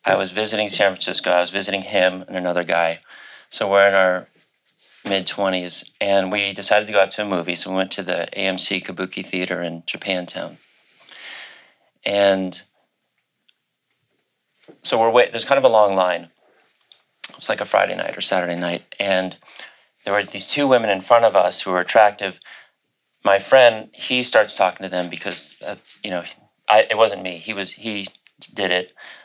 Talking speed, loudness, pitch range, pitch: 180 wpm, -19 LUFS, 90-100 Hz, 95 Hz